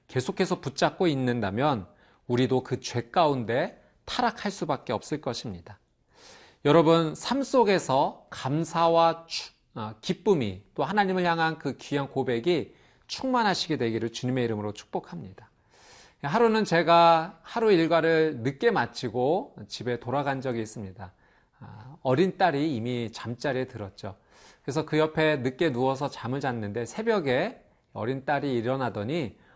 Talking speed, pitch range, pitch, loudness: 295 characters per minute, 120-165 Hz, 140 Hz, -27 LUFS